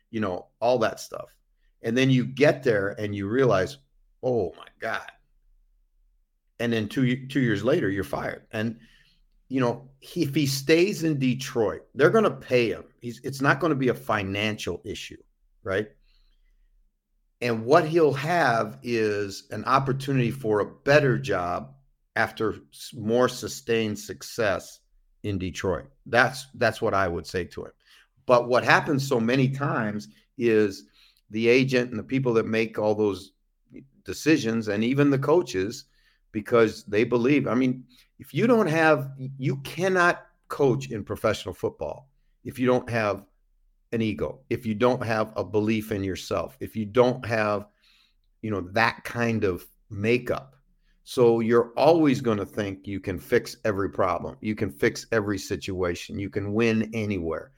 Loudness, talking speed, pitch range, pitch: -25 LUFS, 160 wpm, 105-130 Hz, 115 Hz